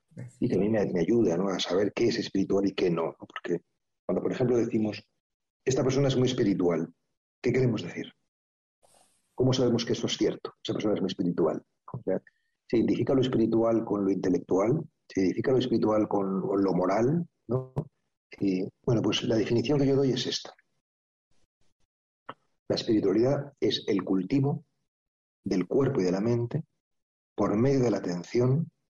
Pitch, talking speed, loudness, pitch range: 115 Hz, 170 wpm, -28 LUFS, 95-130 Hz